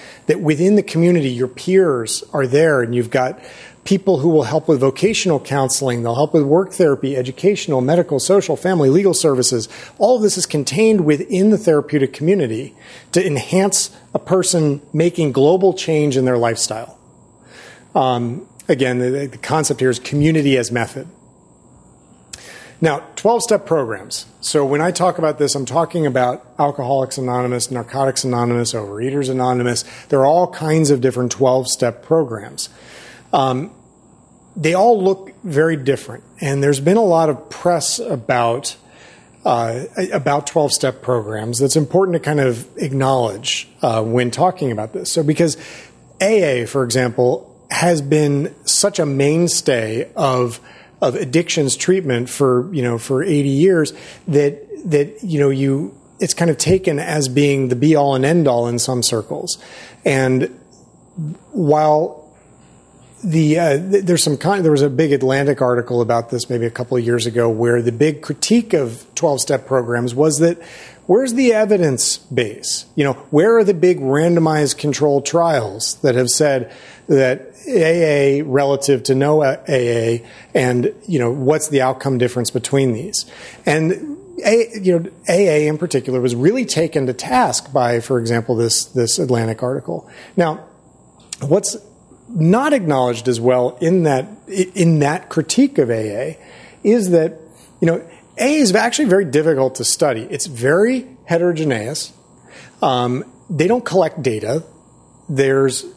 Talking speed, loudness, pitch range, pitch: 150 wpm, -17 LUFS, 125-170 Hz, 145 Hz